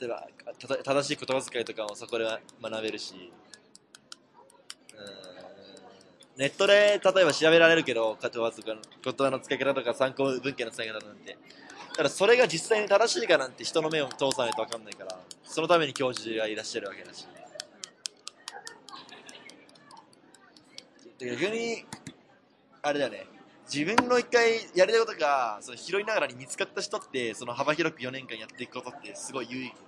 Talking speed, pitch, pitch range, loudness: 320 characters per minute, 135 Hz, 120-180 Hz, -27 LUFS